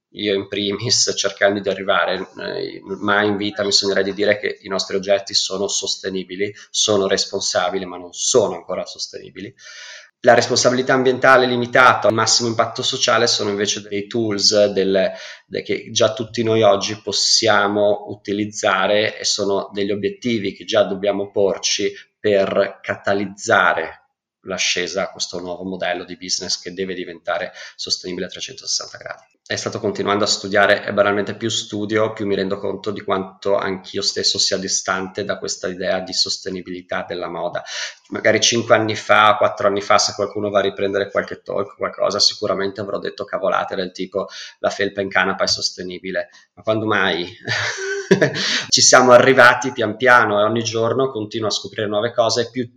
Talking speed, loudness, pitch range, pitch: 165 wpm, -18 LUFS, 95-110 Hz, 100 Hz